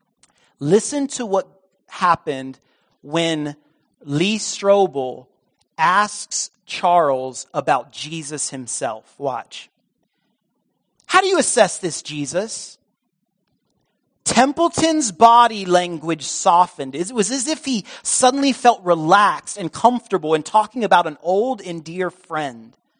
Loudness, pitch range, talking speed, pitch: -19 LUFS, 155-230 Hz, 105 wpm, 185 Hz